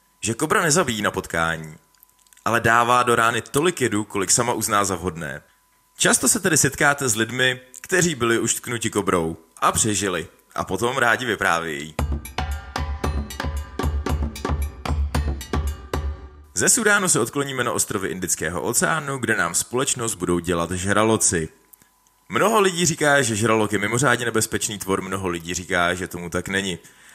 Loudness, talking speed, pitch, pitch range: -21 LUFS, 140 wpm, 100 Hz, 80-120 Hz